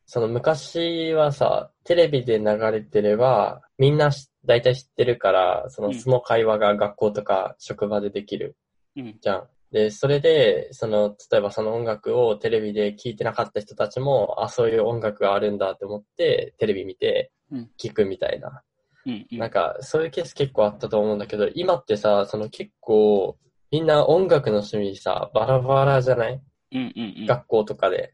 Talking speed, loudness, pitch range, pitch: 330 characters per minute, -22 LUFS, 105-170 Hz, 125 Hz